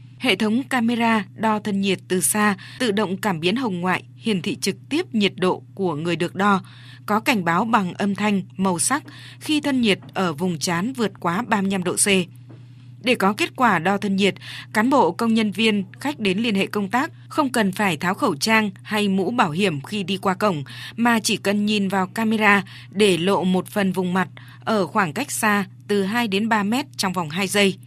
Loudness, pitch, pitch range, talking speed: -21 LUFS, 200 Hz, 185-220 Hz, 215 wpm